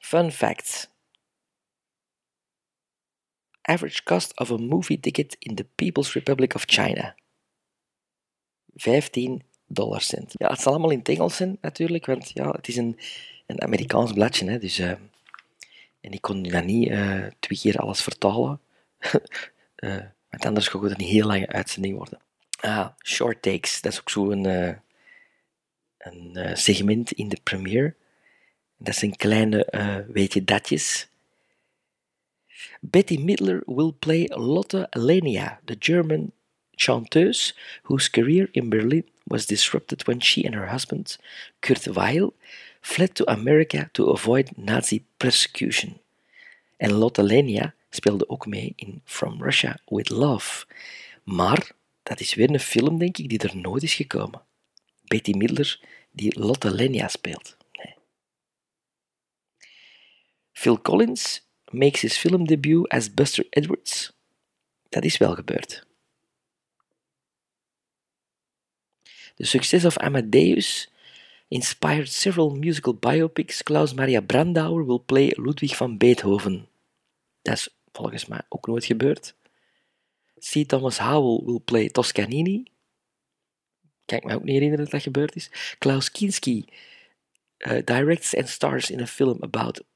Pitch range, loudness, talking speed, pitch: 105-155 Hz, -23 LUFS, 135 wpm, 125 Hz